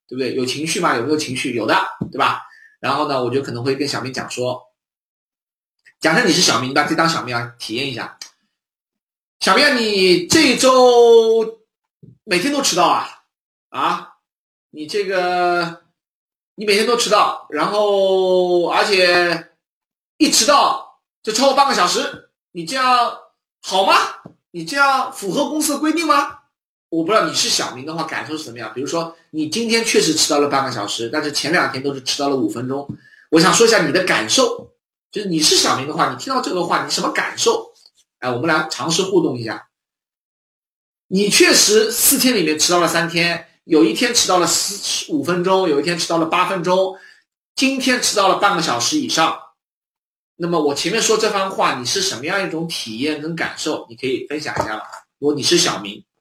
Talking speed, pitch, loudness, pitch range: 275 characters per minute, 185 Hz, -16 LUFS, 155-250 Hz